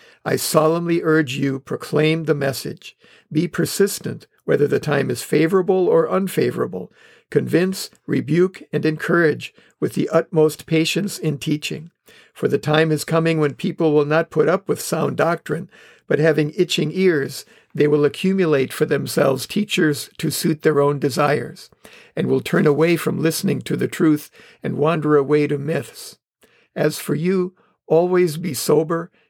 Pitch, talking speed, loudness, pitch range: 155 Hz, 155 wpm, -19 LUFS, 150-170 Hz